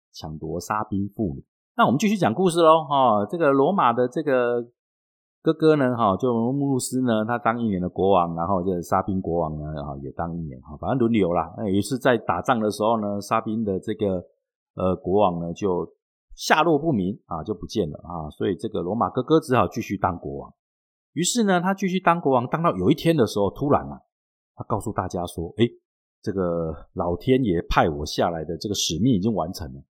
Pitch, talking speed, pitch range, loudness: 105 Hz, 300 characters per minute, 85-130 Hz, -23 LUFS